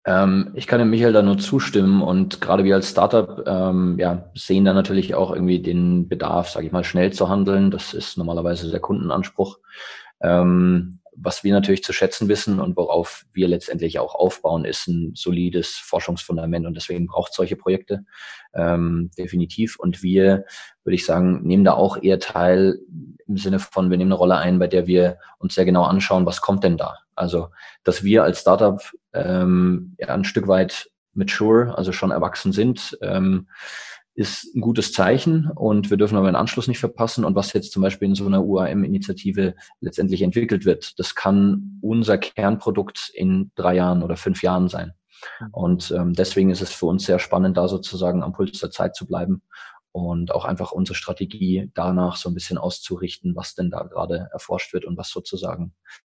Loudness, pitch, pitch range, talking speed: -20 LUFS, 95 Hz, 90-100 Hz, 185 wpm